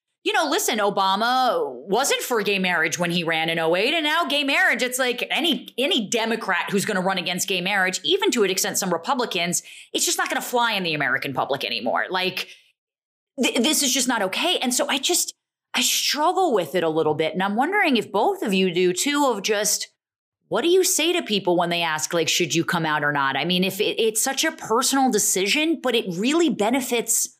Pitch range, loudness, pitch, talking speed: 185-300 Hz, -21 LUFS, 225 Hz, 225 wpm